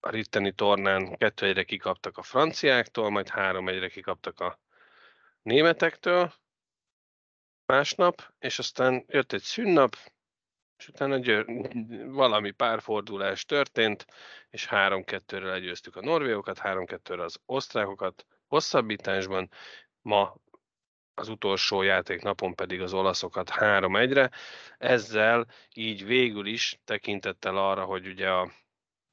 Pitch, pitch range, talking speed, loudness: 100 Hz, 95-125 Hz, 105 wpm, -27 LUFS